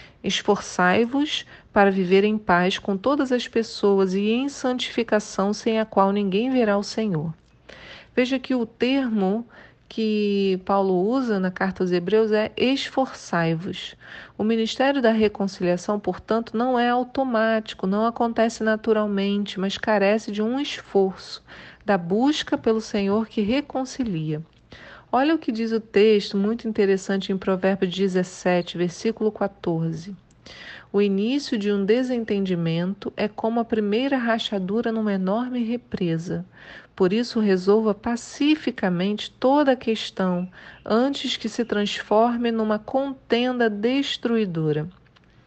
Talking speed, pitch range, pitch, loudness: 125 wpm, 195-235 Hz, 215 Hz, -23 LUFS